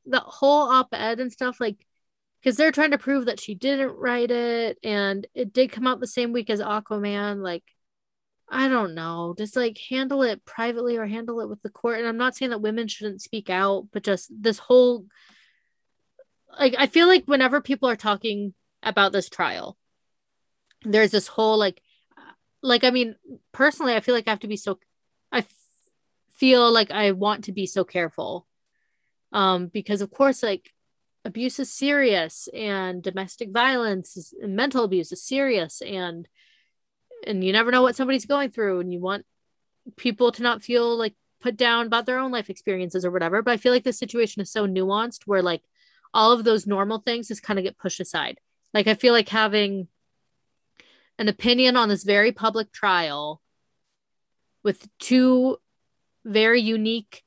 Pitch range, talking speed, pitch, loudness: 200-250 Hz, 180 wpm, 225 Hz, -23 LUFS